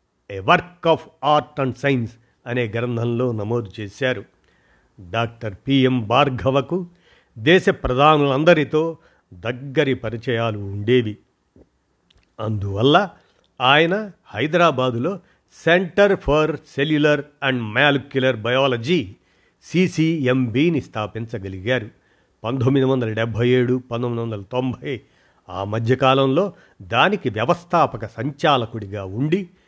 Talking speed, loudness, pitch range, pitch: 85 wpm, -20 LUFS, 115-150 Hz, 130 Hz